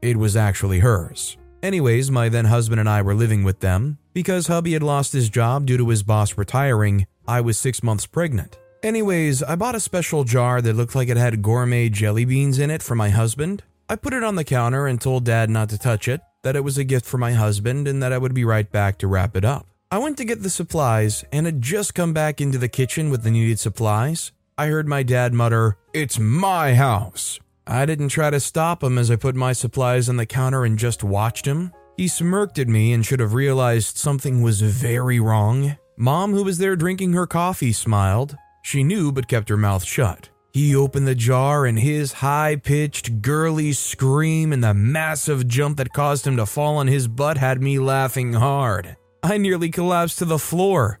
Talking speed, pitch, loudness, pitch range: 215 wpm, 130 Hz, -20 LUFS, 115-150 Hz